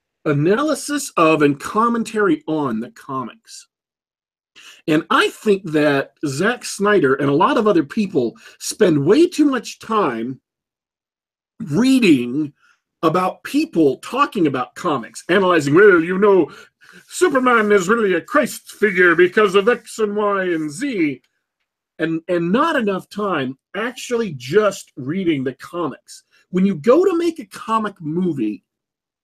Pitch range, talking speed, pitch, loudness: 170-245 Hz, 135 wpm, 210 Hz, -18 LUFS